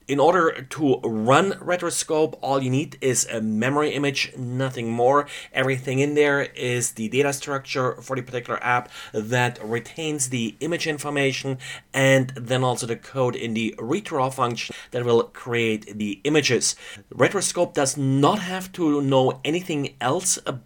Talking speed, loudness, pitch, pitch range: 155 wpm, -23 LUFS, 130 Hz, 120-145 Hz